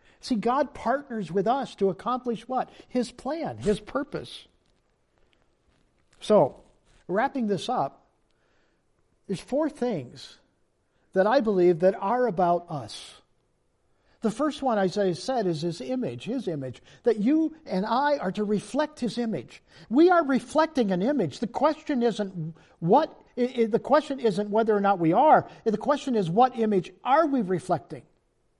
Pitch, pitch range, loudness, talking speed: 225 Hz, 185-260 Hz, -26 LUFS, 145 wpm